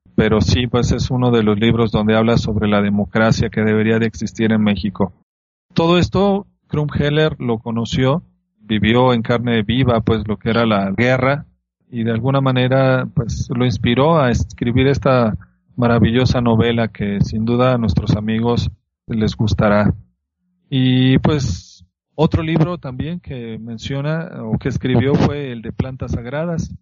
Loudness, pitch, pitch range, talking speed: -17 LUFS, 120 Hz, 110-135 Hz, 155 wpm